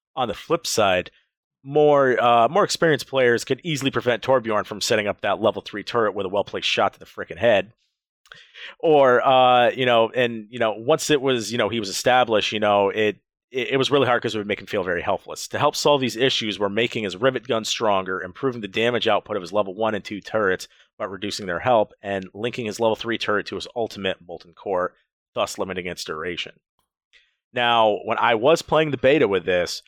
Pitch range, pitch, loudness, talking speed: 105-135 Hz, 120 Hz, -21 LUFS, 220 wpm